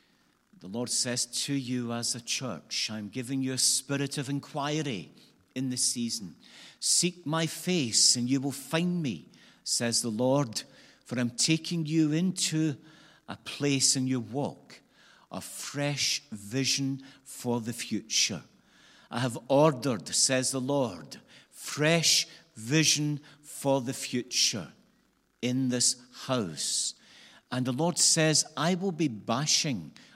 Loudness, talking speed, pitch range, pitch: -28 LUFS, 135 wpm, 125-155 Hz, 135 Hz